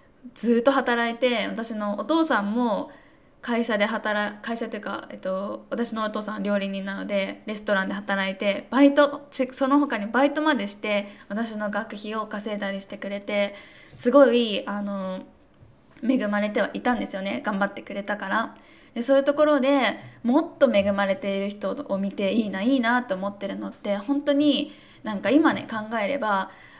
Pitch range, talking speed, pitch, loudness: 200-270 Hz, 340 characters per minute, 215 Hz, -24 LUFS